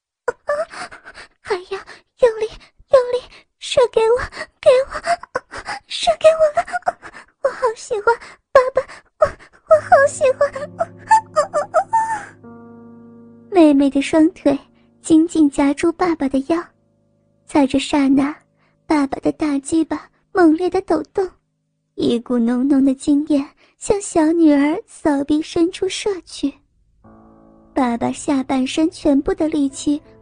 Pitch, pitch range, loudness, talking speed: 315 Hz, 285-385 Hz, -18 LUFS, 175 characters per minute